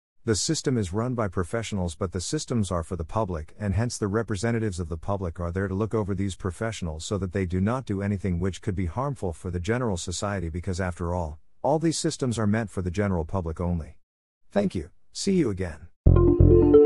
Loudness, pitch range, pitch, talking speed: -27 LUFS, 90-110 Hz, 100 Hz, 215 wpm